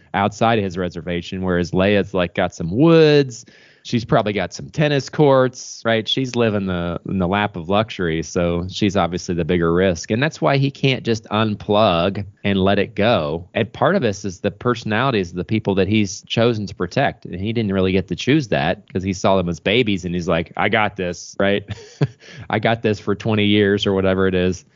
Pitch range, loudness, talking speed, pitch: 90-115 Hz, -19 LUFS, 215 wpm, 100 Hz